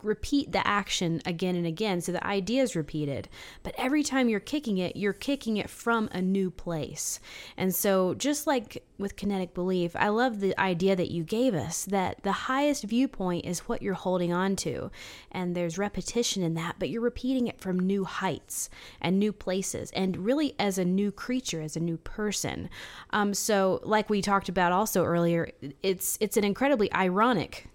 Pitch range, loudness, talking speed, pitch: 175-220 Hz, -28 LUFS, 190 wpm, 195 Hz